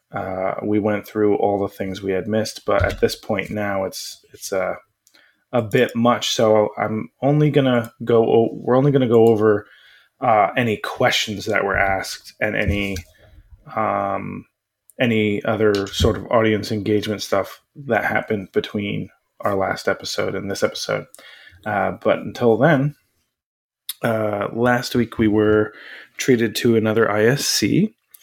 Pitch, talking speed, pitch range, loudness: 110 Hz, 155 wpm, 105-120 Hz, -20 LUFS